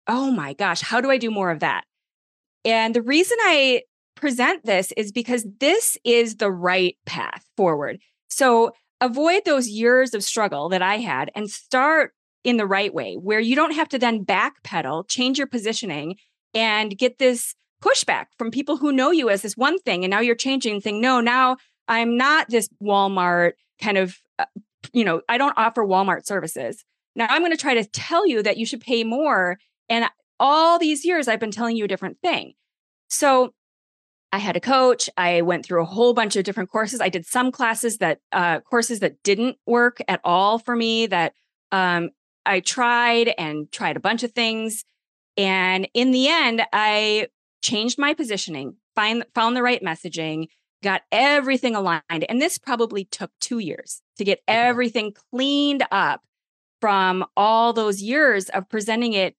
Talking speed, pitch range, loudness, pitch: 180 wpm, 200-255 Hz, -21 LUFS, 230 Hz